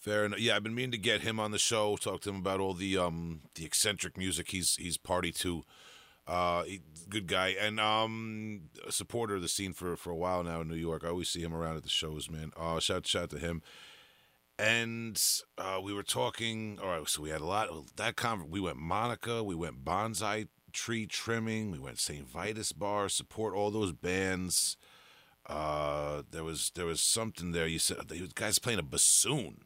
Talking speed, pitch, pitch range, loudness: 215 wpm, 95 Hz, 85-110 Hz, -33 LUFS